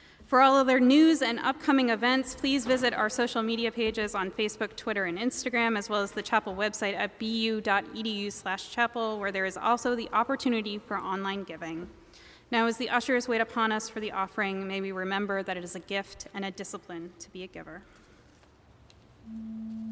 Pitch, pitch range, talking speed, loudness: 220 Hz, 195-235 Hz, 180 wpm, -28 LUFS